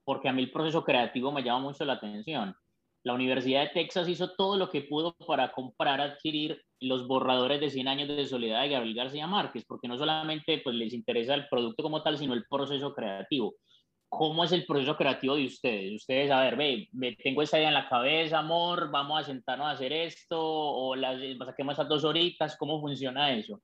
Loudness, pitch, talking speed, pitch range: -30 LUFS, 145 Hz, 210 wpm, 130-155 Hz